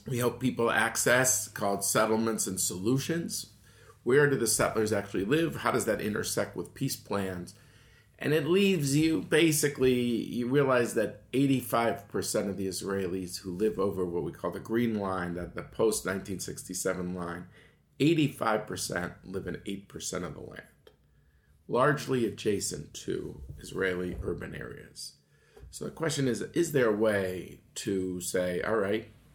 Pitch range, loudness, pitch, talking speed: 95-130 Hz, -29 LUFS, 110 Hz, 145 wpm